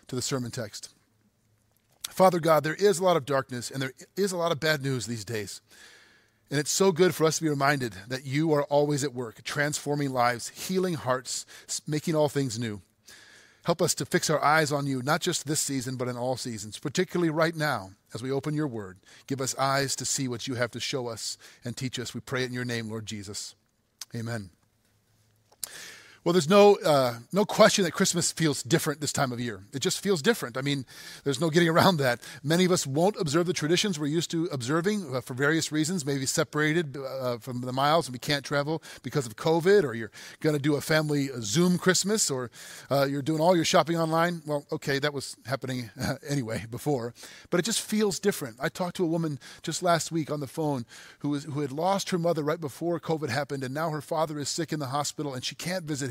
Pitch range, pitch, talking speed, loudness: 125-165 Hz, 145 Hz, 225 wpm, -27 LUFS